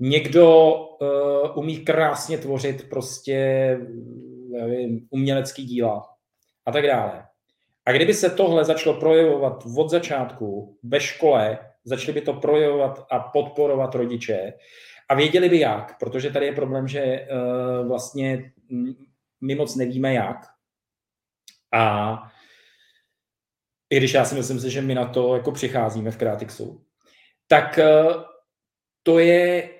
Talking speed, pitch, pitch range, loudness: 125 wpm, 135 Hz, 125-150 Hz, -21 LUFS